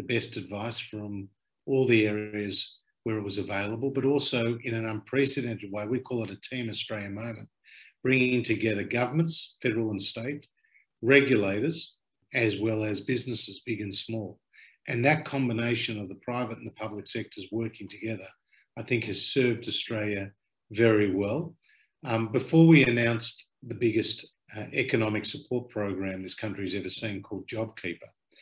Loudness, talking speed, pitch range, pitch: -28 LUFS, 150 wpm, 105-125 Hz, 115 Hz